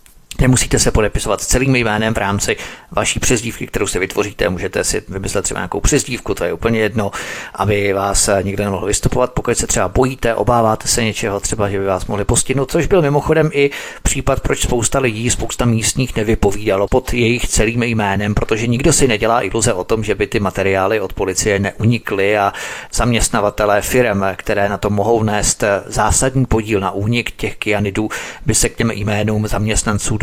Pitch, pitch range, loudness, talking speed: 110 Hz, 100-120 Hz, -16 LUFS, 180 wpm